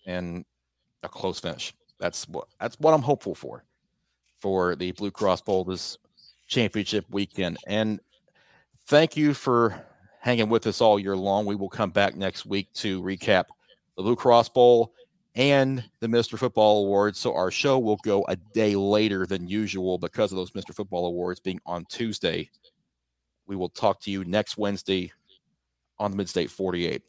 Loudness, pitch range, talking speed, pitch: -25 LUFS, 90-115 Hz, 170 wpm, 100 Hz